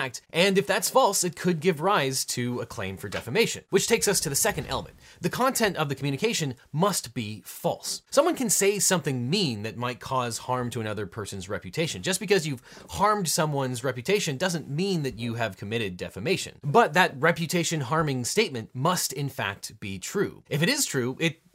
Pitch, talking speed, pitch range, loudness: 155 Hz, 190 wpm, 125-190 Hz, -26 LUFS